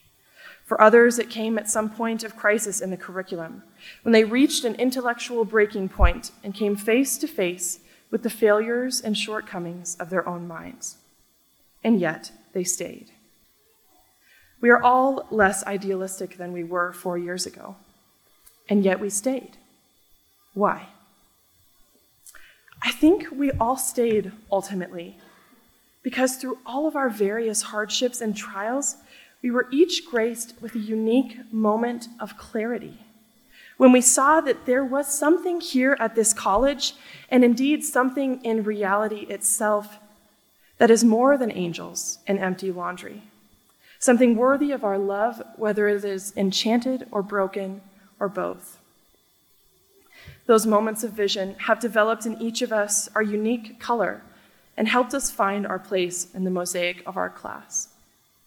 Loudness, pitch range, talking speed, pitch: -23 LUFS, 200-245 Hz, 145 wpm, 220 Hz